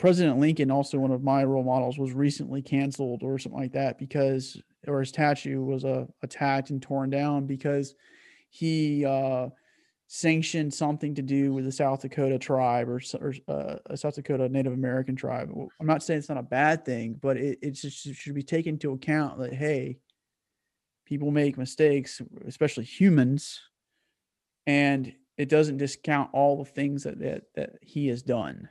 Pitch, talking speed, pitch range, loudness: 140 Hz, 175 wpm, 130-145 Hz, -27 LUFS